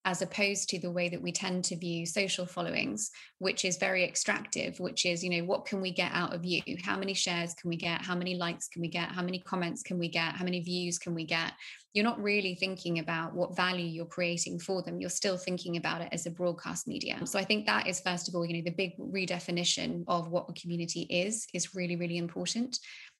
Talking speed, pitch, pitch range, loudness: 240 wpm, 180 Hz, 175-190 Hz, -32 LUFS